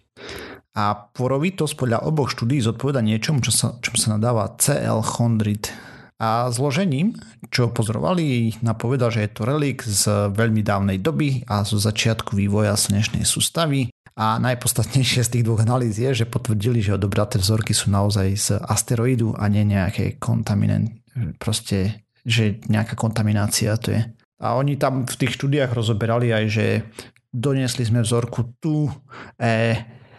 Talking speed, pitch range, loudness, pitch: 145 wpm, 110-125 Hz, -21 LUFS, 115 Hz